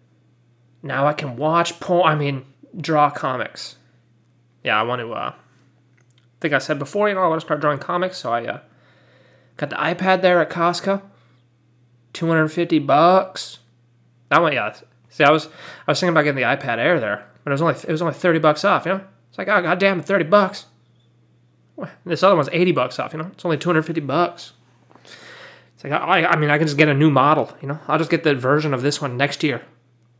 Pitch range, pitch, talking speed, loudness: 125-170 Hz, 150 Hz, 220 wpm, -19 LUFS